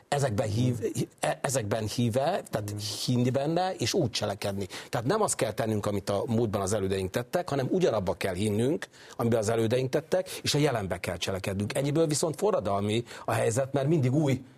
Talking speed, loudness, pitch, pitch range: 175 wpm, -28 LUFS, 120 Hz, 105-140 Hz